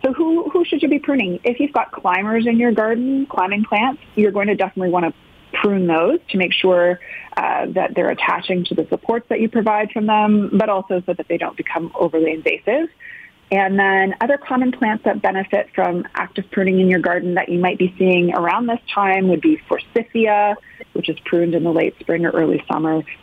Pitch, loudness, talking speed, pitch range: 200 Hz, -18 LUFS, 210 wpm, 180-235 Hz